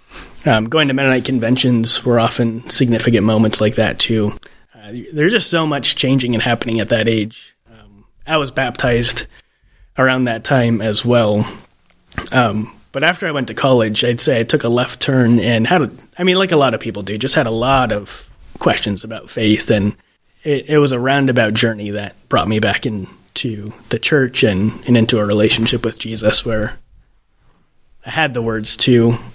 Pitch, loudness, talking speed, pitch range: 115 Hz, -15 LUFS, 185 wpm, 110-130 Hz